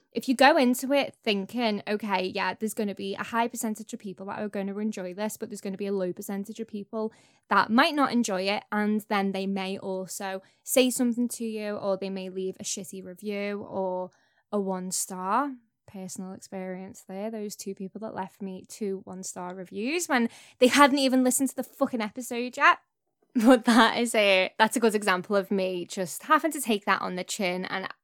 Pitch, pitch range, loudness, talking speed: 205 Hz, 190-235 Hz, -27 LUFS, 215 wpm